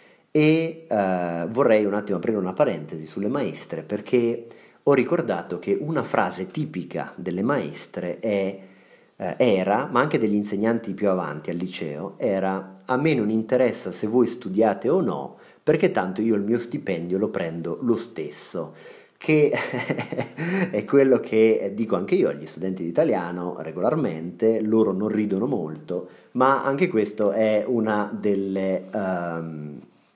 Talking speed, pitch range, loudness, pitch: 145 wpm, 95-120 Hz, -24 LUFS, 105 Hz